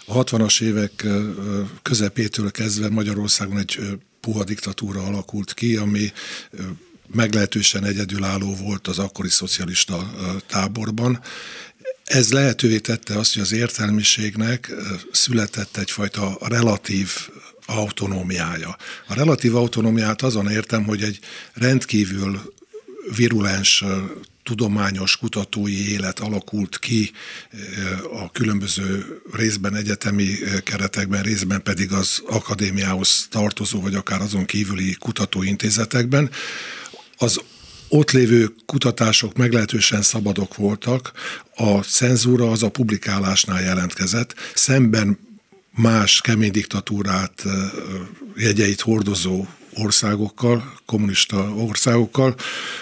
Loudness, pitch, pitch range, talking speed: -20 LUFS, 105 Hz, 100-115 Hz, 90 wpm